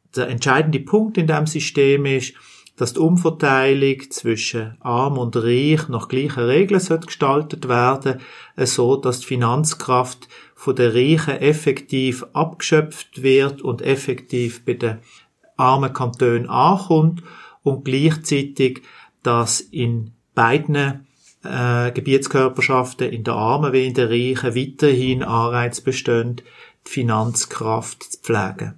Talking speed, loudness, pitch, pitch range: 115 wpm, -19 LUFS, 130 Hz, 120-145 Hz